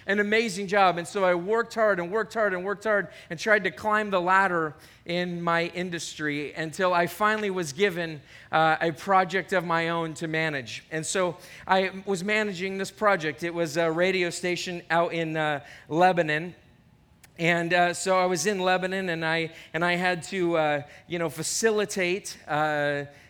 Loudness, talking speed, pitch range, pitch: -26 LUFS, 180 wpm, 160-190 Hz, 175 Hz